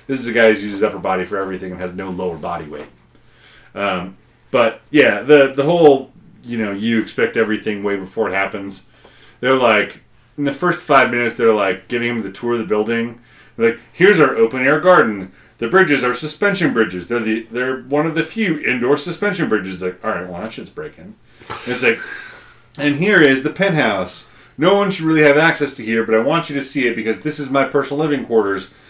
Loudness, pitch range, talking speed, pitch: -16 LUFS, 110-145 Hz, 220 wpm, 120 Hz